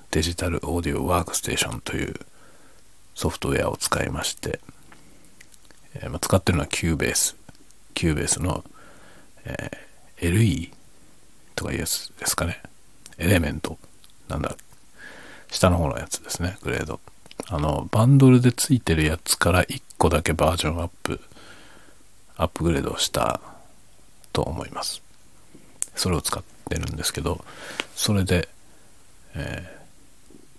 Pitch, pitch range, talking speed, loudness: 85 Hz, 80-100 Hz, 285 characters per minute, -24 LUFS